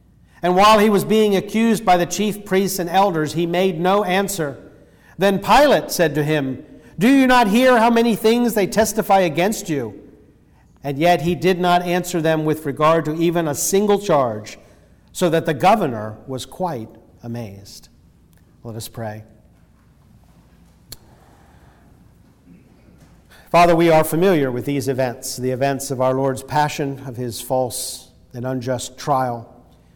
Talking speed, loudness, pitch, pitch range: 150 wpm, -18 LUFS, 155 Hz, 130-190 Hz